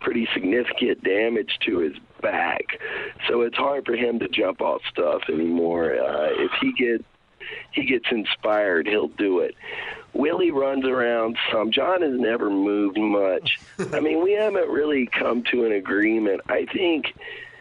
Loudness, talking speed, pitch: -23 LUFS, 155 wpm, 225 Hz